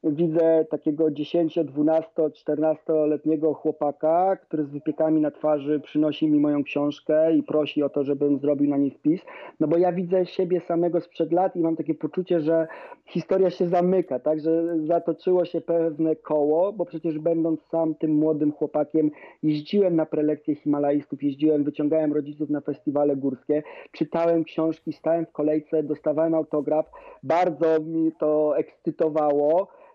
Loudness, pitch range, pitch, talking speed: -24 LUFS, 150-165 Hz, 155 Hz, 150 wpm